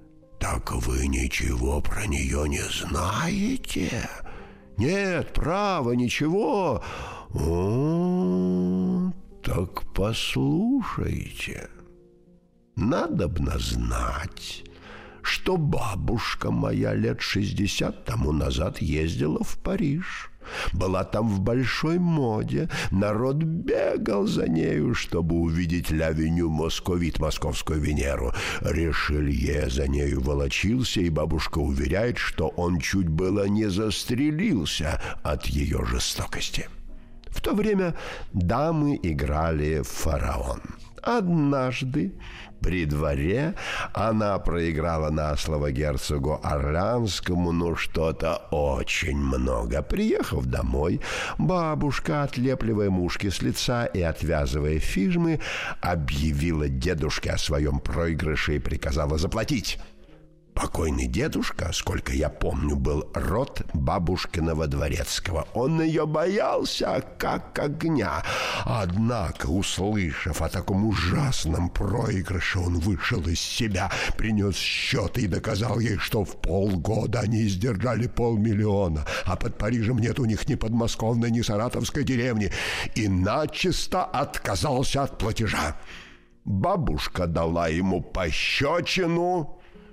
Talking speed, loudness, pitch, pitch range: 100 wpm, -26 LUFS, 95 Hz, 80-120 Hz